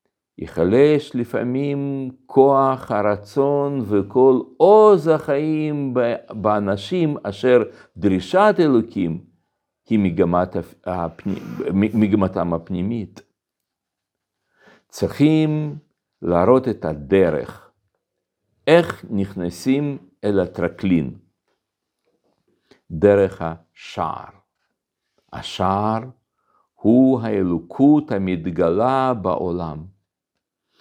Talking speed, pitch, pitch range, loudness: 55 wpm, 105 Hz, 95-135 Hz, -19 LUFS